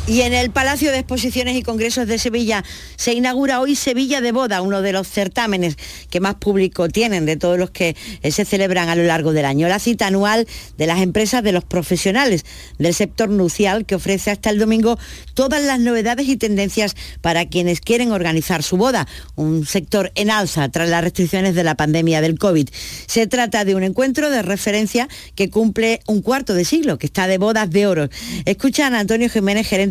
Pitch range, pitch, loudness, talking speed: 180-235 Hz, 205 Hz, -17 LUFS, 195 wpm